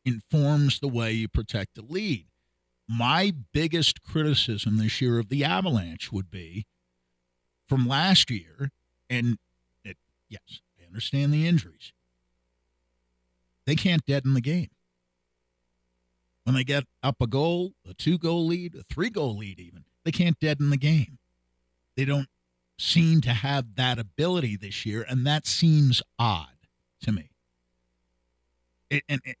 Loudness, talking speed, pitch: -26 LUFS, 145 wpm, 115 Hz